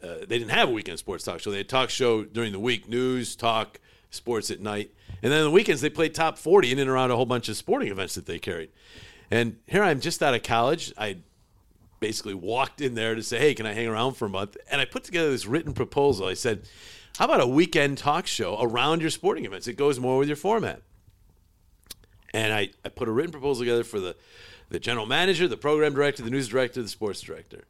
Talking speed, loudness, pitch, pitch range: 245 wpm, -25 LUFS, 125 Hz, 110-145 Hz